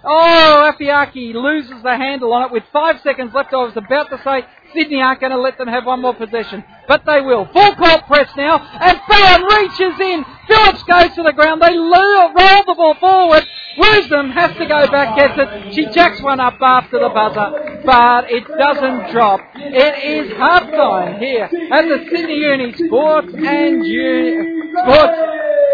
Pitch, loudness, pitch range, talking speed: 295 Hz, -12 LUFS, 265-335 Hz, 180 wpm